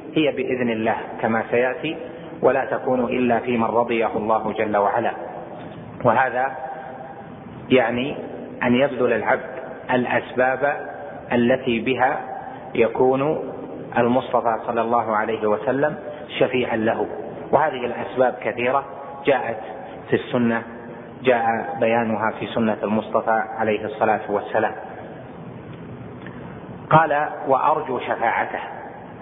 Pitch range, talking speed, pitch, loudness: 110-130 Hz, 95 wpm, 120 Hz, -21 LUFS